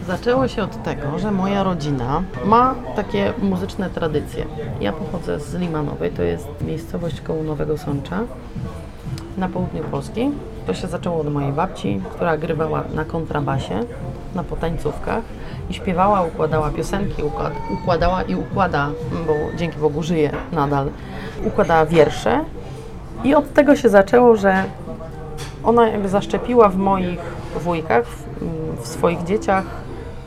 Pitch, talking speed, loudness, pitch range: 160 Hz, 135 wpm, -20 LUFS, 150-195 Hz